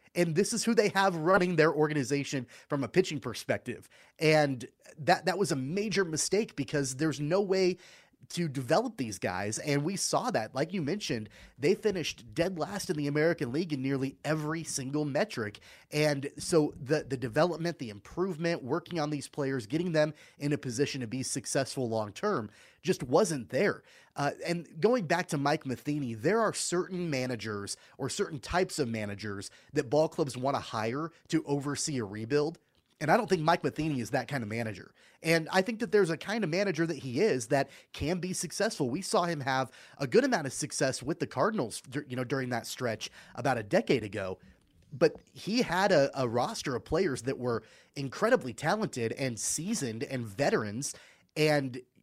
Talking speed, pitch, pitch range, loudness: 190 wpm, 150 Hz, 130-170 Hz, -31 LUFS